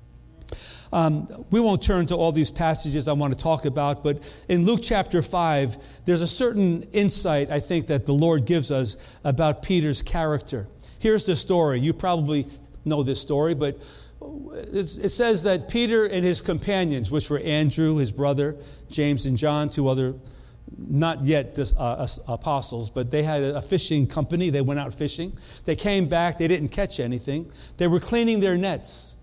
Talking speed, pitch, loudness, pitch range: 175 wpm, 150 Hz, -24 LUFS, 140-175 Hz